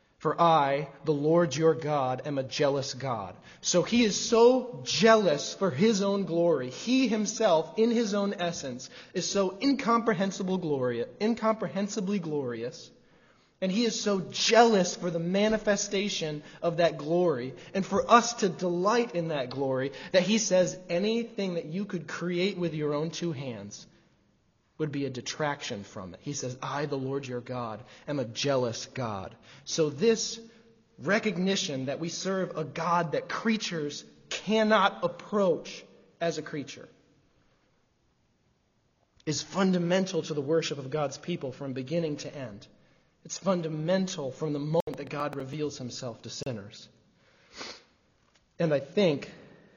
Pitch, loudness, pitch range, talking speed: 165 Hz, -28 LUFS, 140-195 Hz, 145 wpm